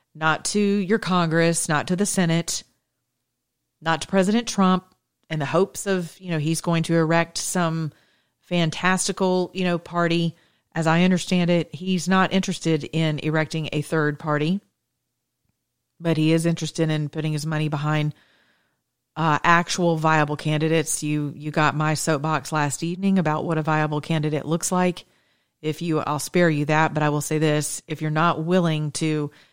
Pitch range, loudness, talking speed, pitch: 155-175 Hz, -22 LUFS, 165 wpm, 160 Hz